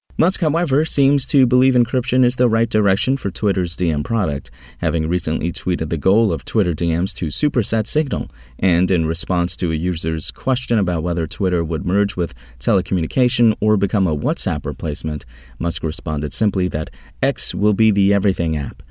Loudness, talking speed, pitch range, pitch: -18 LUFS, 170 wpm, 80-110 Hz, 90 Hz